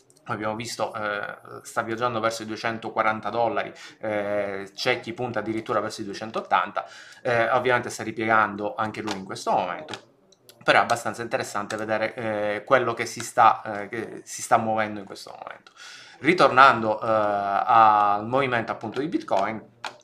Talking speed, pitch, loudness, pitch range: 155 wpm, 110 Hz, -24 LUFS, 105-120 Hz